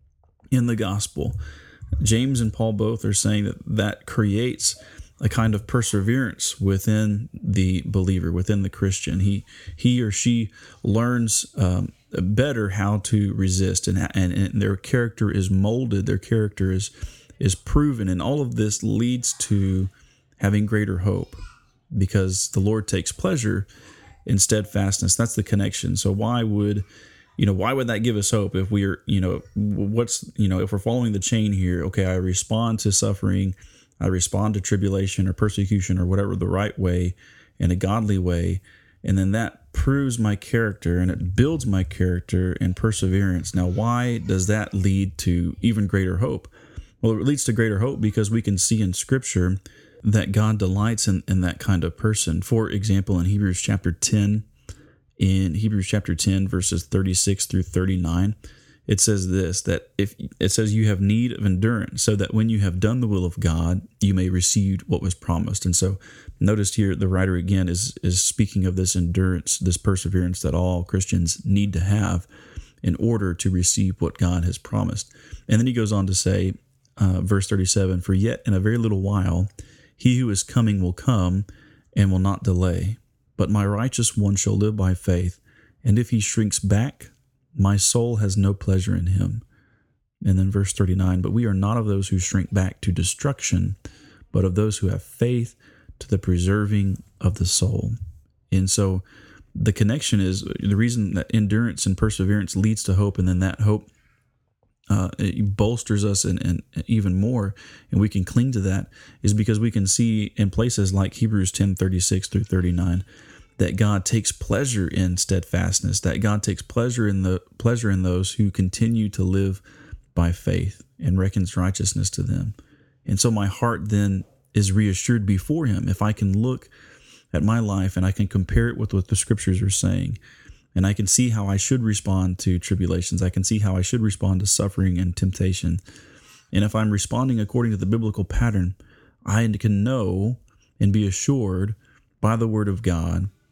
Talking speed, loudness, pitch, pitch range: 180 wpm, -22 LUFS, 100 Hz, 95-110 Hz